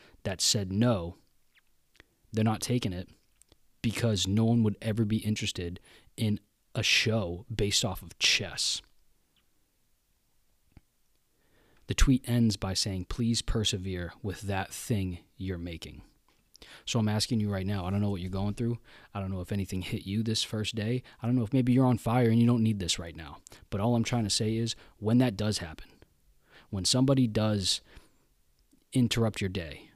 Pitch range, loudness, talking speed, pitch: 95-115 Hz, -29 LUFS, 175 wpm, 105 Hz